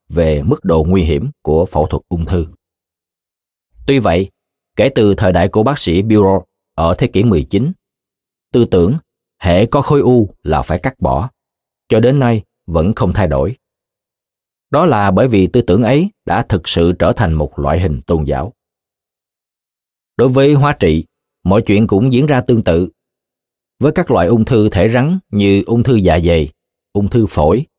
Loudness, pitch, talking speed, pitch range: -13 LUFS, 95 Hz, 180 wpm, 85-115 Hz